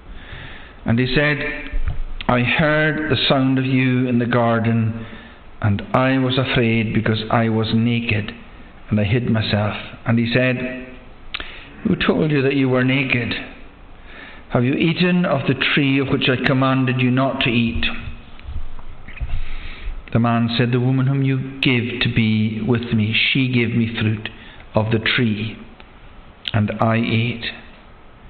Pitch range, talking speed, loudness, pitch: 110-130 Hz, 150 wpm, -19 LUFS, 120 Hz